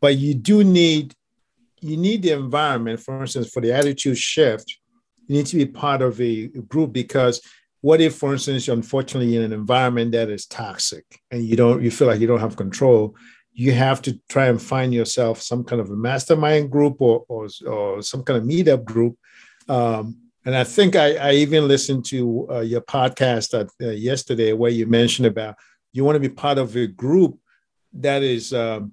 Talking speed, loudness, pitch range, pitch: 195 wpm, -19 LUFS, 115-145 Hz, 130 Hz